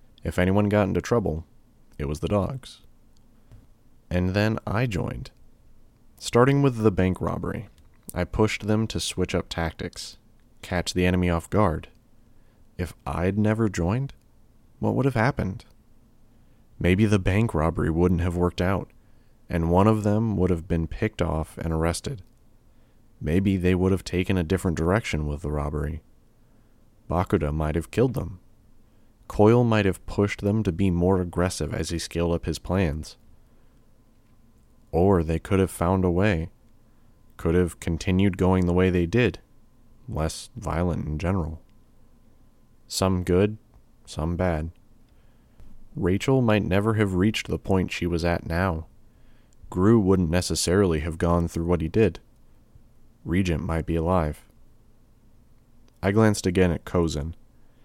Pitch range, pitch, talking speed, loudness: 85-110 Hz, 95 Hz, 145 wpm, -24 LUFS